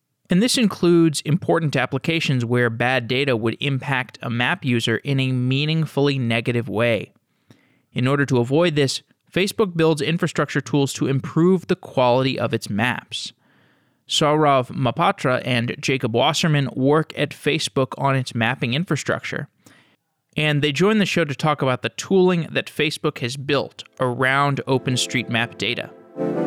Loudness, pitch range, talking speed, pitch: -20 LUFS, 125-155 Hz, 145 wpm, 140 Hz